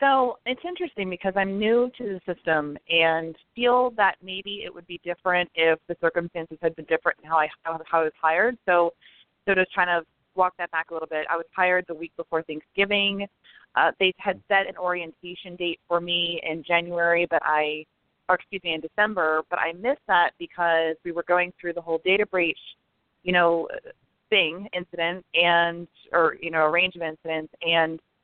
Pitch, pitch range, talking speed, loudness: 175 Hz, 165-190 Hz, 195 wpm, -24 LUFS